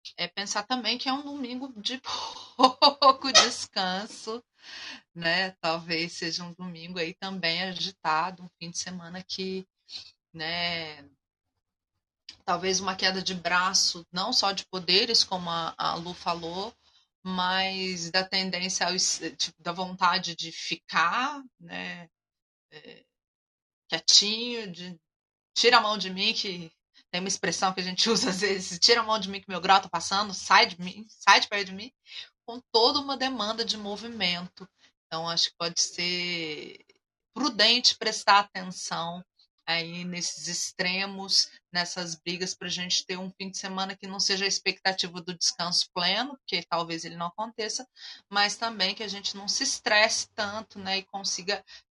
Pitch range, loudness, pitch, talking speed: 175-210 Hz, -26 LUFS, 190 Hz, 155 wpm